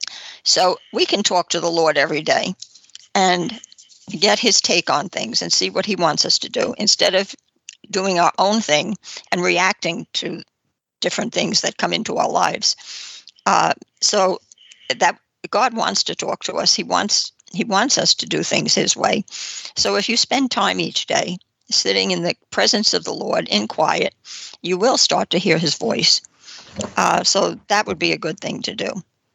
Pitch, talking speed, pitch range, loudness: 200 Hz, 185 wpm, 180-230 Hz, -18 LUFS